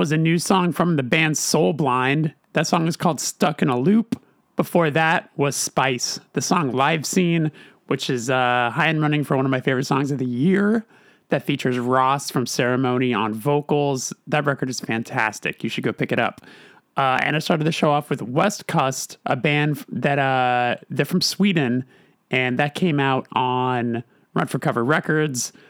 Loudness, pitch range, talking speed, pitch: -21 LUFS, 130-165 Hz, 195 wpm, 145 Hz